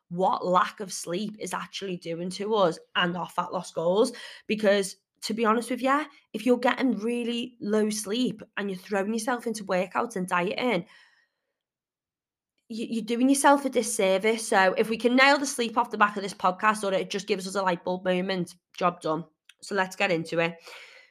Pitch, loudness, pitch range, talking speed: 215 Hz, -26 LUFS, 190-245 Hz, 195 wpm